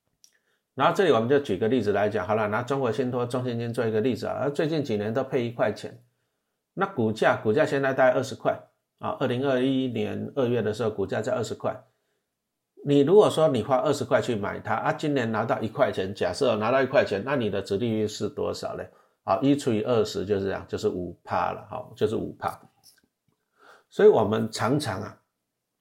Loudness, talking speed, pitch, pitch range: -25 LUFS, 305 characters per minute, 125 Hz, 110-135 Hz